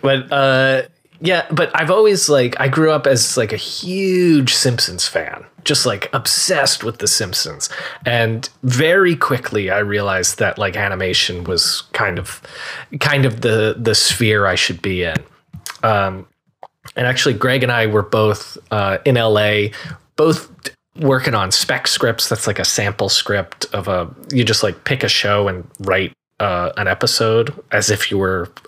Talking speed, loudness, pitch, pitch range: 165 wpm, -16 LUFS, 120 Hz, 105-135 Hz